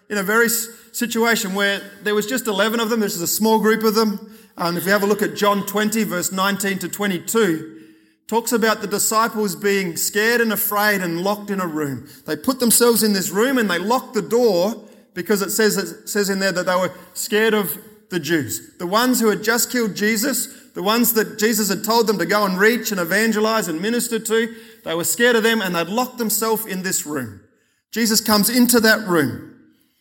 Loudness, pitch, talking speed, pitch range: -19 LUFS, 215 Hz, 220 wpm, 195-225 Hz